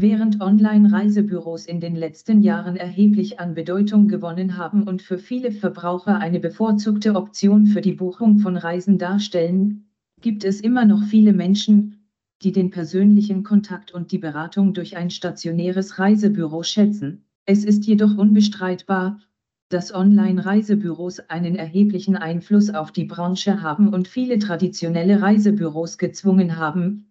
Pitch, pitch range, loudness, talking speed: 195 Hz, 180-210 Hz, -19 LUFS, 135 wpm